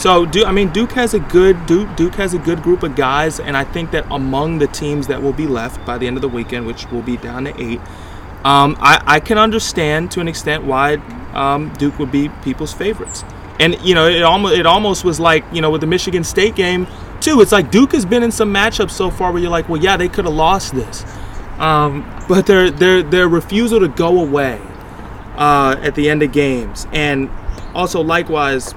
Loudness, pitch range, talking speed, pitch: -14 LUFS, 135-180 Hz, 225 wpm, 155 Hz